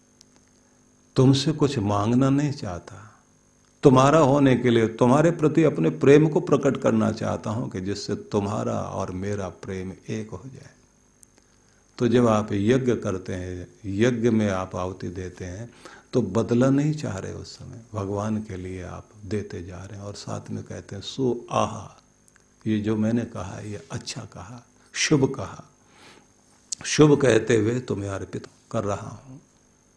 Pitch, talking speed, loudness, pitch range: 110 Hz, 155 wpm, -23 LUFS, 100-125 Hz